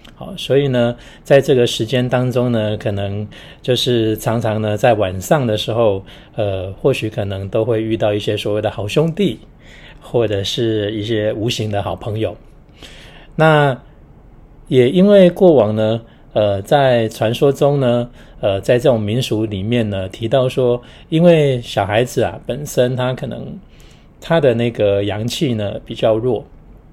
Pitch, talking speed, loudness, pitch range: 115 Hz, 220 characters per minute, -16 LUFS, 105-130 Hz